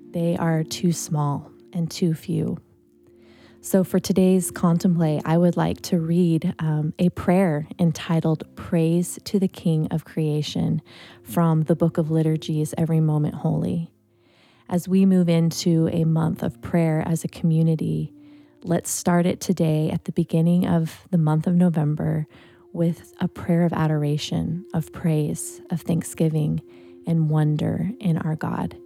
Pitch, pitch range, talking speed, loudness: 165 Hz, 155-175 Hz, 150 wpm, -23 LUFS